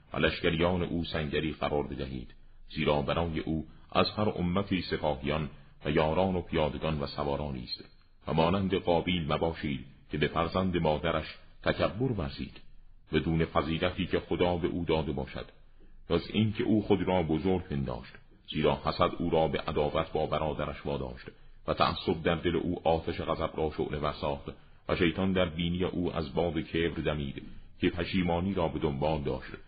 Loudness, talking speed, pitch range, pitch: -31 LUFS, 160 wpm, 75-90 Hz, 80 Hz